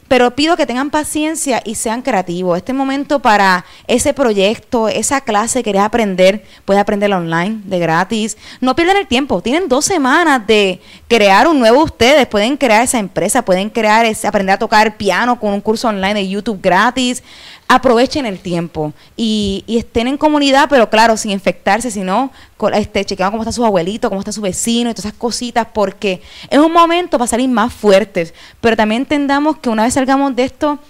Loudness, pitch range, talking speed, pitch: -13 LUFS, 200-260 Hz, 190 wpm, 225 Hz